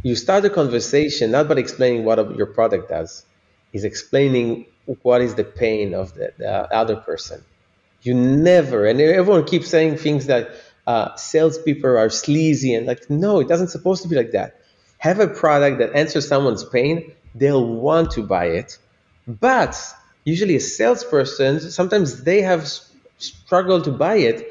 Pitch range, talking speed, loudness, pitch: 120-170 Hz, 165 wpm, -18 LUFS, 145 Hz